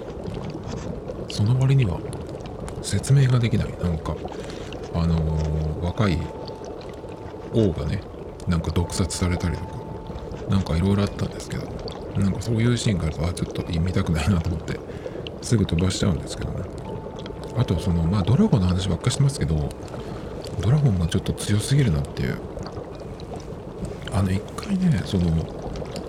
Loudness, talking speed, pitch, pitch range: -25 LUFS, 325 characters per minute, 95 Hz, 85-110 Hz